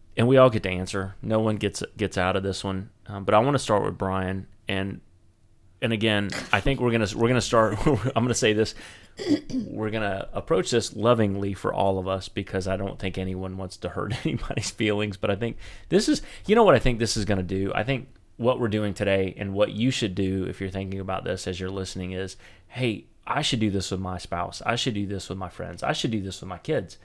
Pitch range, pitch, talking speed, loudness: 95-115 Hz, 100 Hz, 255 wpm, -26 LUFS